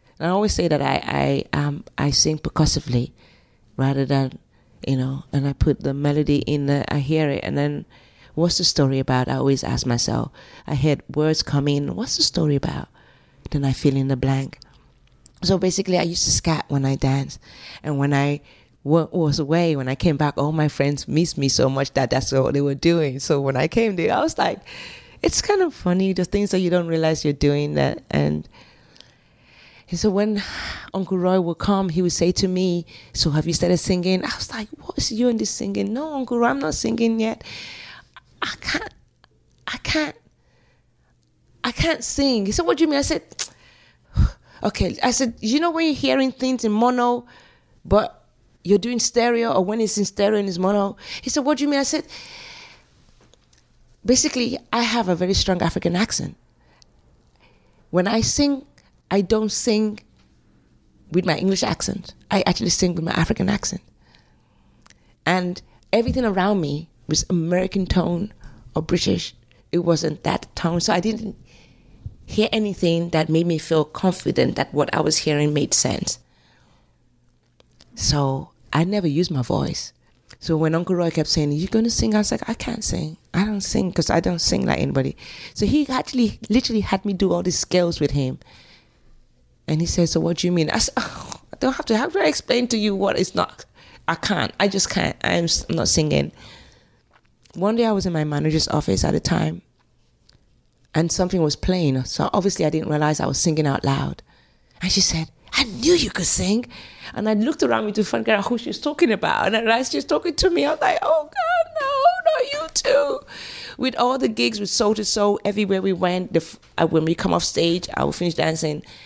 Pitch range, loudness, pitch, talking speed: 145-215 Hz, -21 LUFS, 175 Hz, 200 wpm